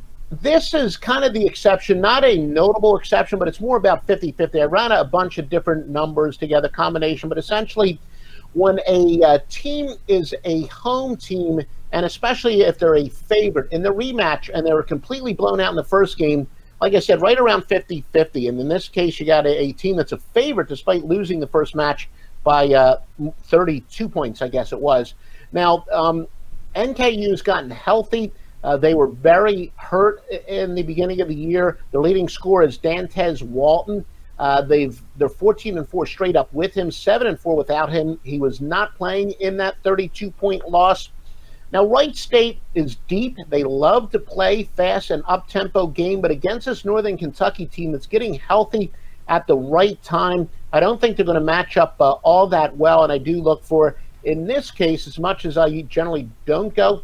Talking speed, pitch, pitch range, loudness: 195 wpm, 175 Hz, 155-200 Hz, -19 LUFS